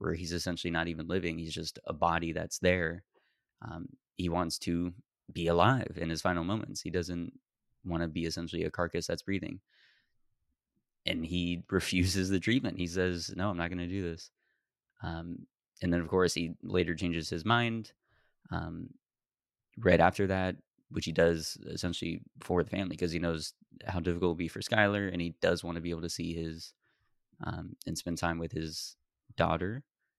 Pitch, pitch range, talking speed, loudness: 85 Hz, 85-95 Hz, 185 wpm, -33 LUFS